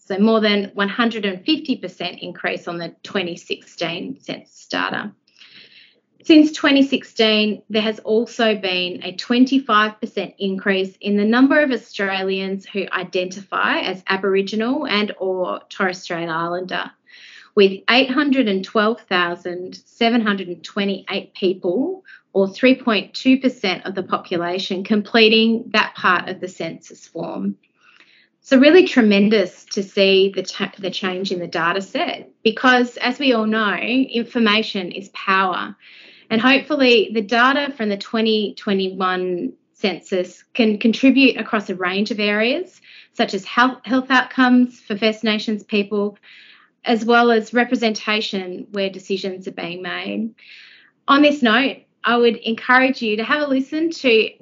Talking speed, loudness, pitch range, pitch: 125 wpm, -18 LUFS, 190-240 Hz, 215 Hz